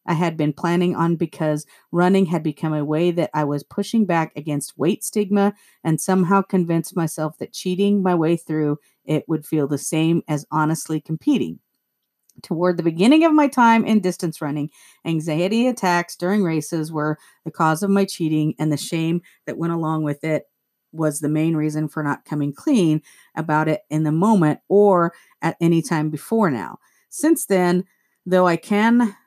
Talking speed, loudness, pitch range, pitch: 180 wpm, -20 LUFS, 155-185 Hz, 165 Hz